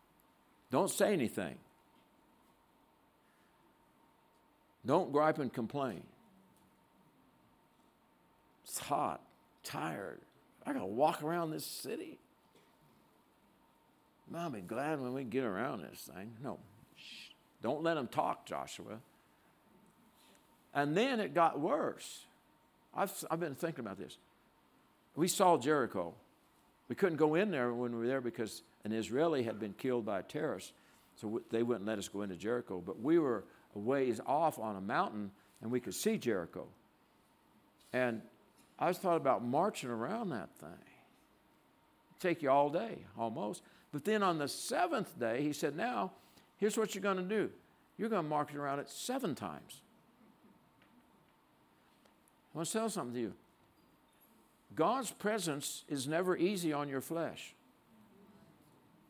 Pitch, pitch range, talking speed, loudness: 145 Hz, 120-175 Hz, 140 wpm, -37 LUFS